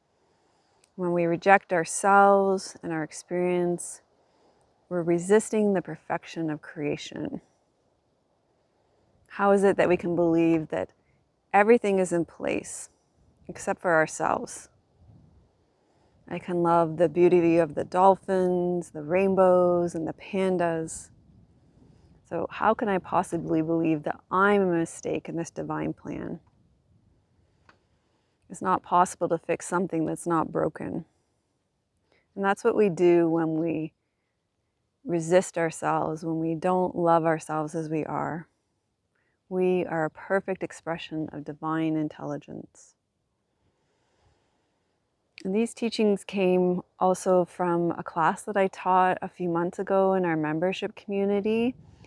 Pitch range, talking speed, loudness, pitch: 160-190 Hz, 125 wpm, -26 LUFS, 175 Hz